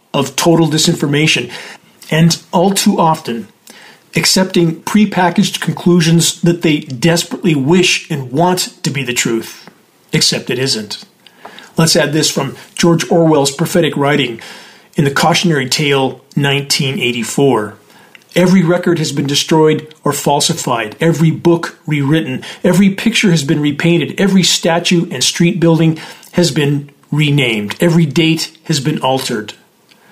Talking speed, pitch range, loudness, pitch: 130 wpm, 145-175 Hz, -13 LUFS, 165 Hz